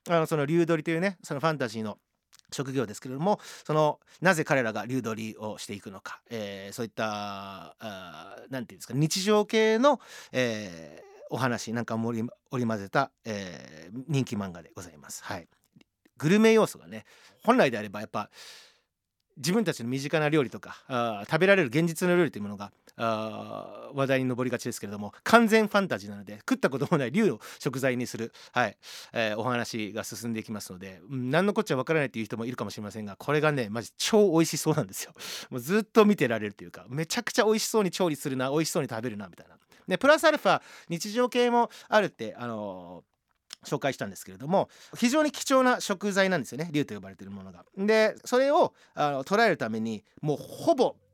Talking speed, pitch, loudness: 415 characters per minute, 135 Hz, -27 LUFS